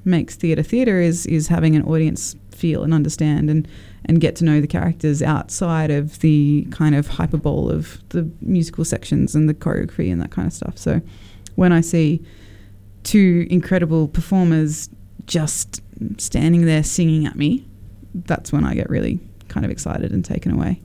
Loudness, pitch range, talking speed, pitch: -19 LUFS, 110-165 Hz, 175 wpm, 155 Hz